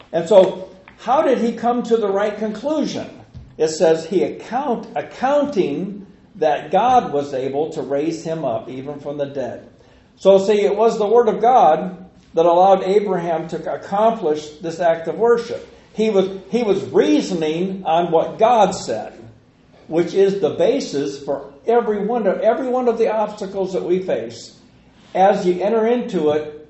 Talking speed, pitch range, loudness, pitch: 165 wpm, 165-225 Hz, -18 LUFS, 195 Hz